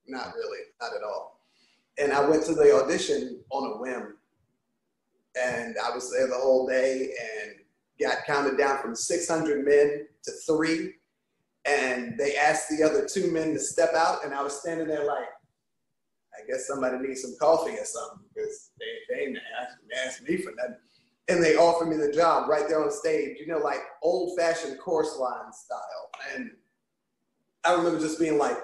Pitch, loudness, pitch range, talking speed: 165 Hz, -27 LUFS, 145-210 Hz, 180 wpm